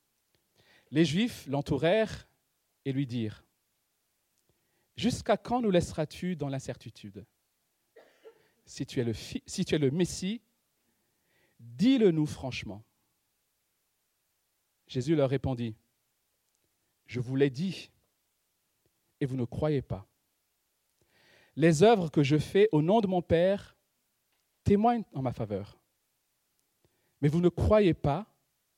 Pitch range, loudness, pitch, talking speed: 125-185 Hz, -29 LUFS, 145 Hz, 110 wpm